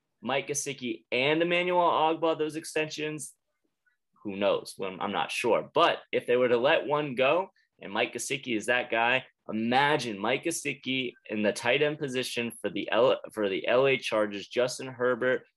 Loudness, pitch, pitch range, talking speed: -28 LUFS, 135 Hz, 120-155 Hz, 170 wpm